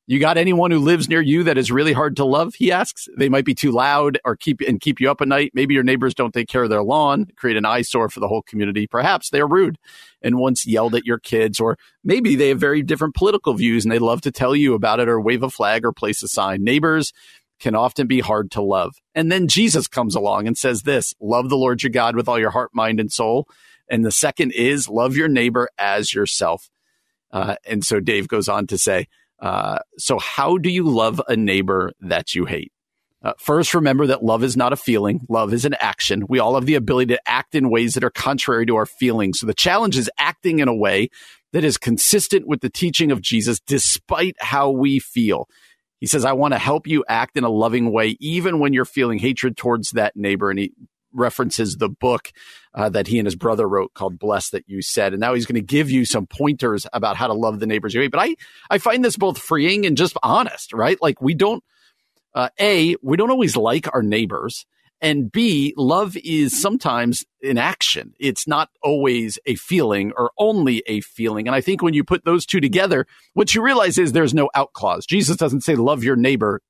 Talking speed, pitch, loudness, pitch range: 230 wpm, 130 Hz, -18 LUFS, 115-155 Hz